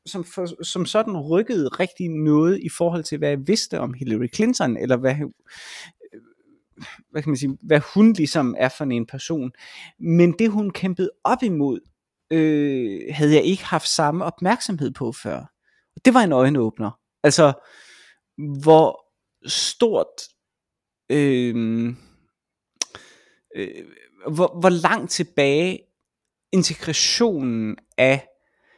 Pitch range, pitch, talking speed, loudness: 140-185 Hz, 160 Hz, 120 wpm, -20 LUFS